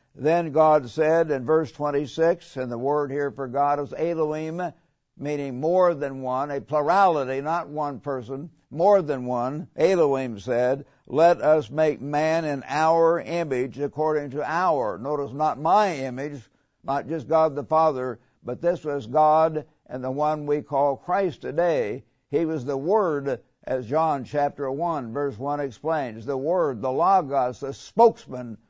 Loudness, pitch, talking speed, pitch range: -24 LUFS, 145 Hz, 155 wpm, 135-160 Hz